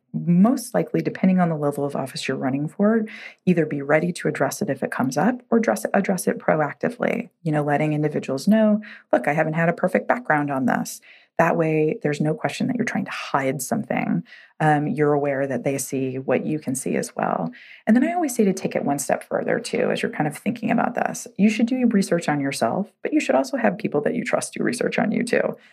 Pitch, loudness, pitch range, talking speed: 170 Hz, -22 LUFS, 145-225 Hz, 245 wpm